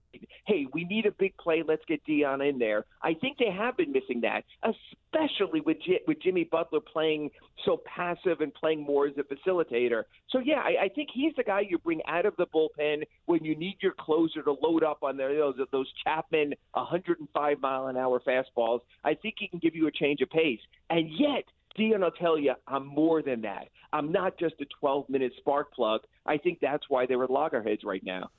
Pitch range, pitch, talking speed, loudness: 140-190 Hz, 155 Hz, 215 wpm, -29 LUFS